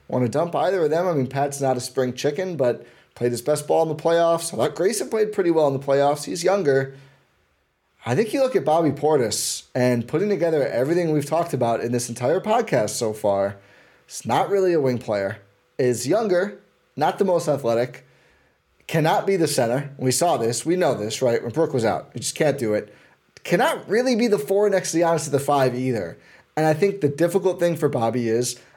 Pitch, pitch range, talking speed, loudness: 145 Hz, 125-170 Hz, 220 wpm, -22 LUFS